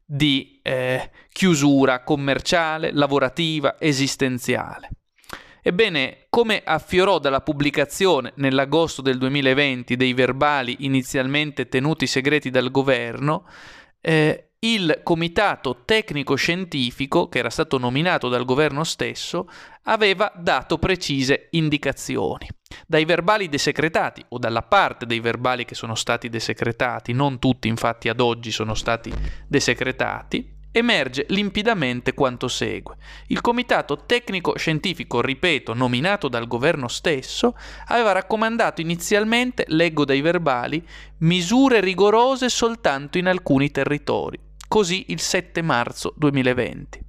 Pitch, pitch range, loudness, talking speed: 145 Hz, 130-175 Hz, -21 LUFS, 110 wpm